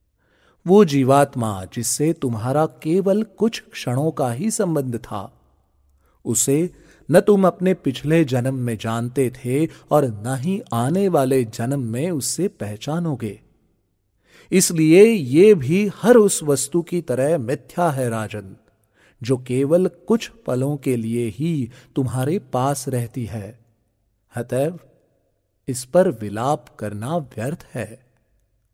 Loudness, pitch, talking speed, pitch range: -20 LUFS, 135 Hz, 120 wpm, 115-165 Hz